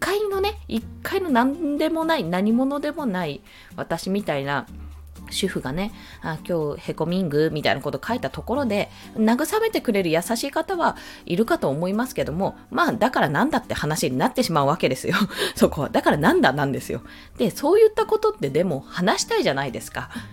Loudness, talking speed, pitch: -23 LUFS, 380 characters per minute, 225 Hz